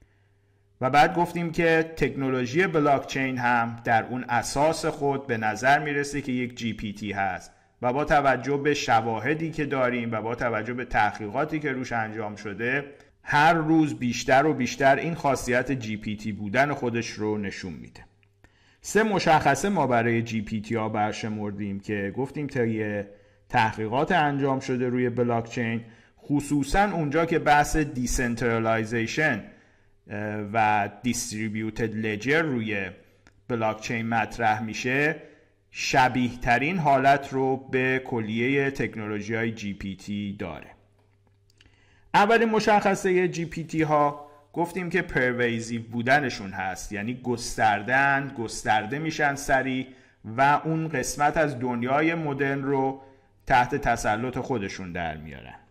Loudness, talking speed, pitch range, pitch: -25 LUFS, 125 wpm, 110-145 Hz, 125 Hz